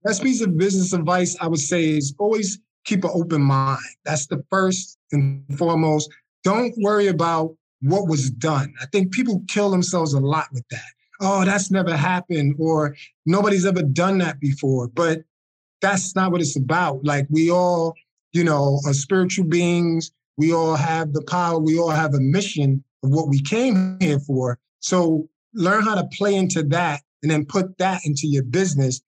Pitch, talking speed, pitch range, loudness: 165 Hz, 180 wpm, 145-185 Hz, -21 LUFS